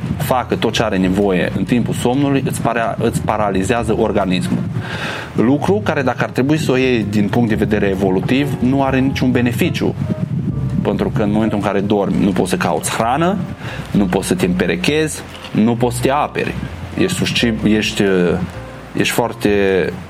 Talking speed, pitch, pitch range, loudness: 165 wpm, 120 Hz, 105-135 Hz, -16 LUFS